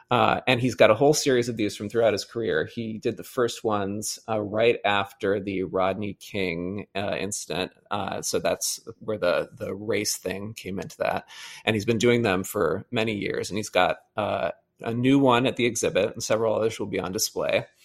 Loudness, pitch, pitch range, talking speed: -25 LUFS, 110 Hz, 100-120 Hz, 210 wpm